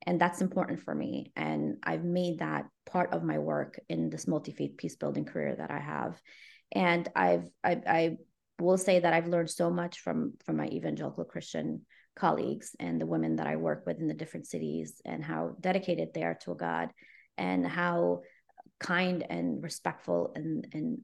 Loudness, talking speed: -32 LUFS, 185 wpm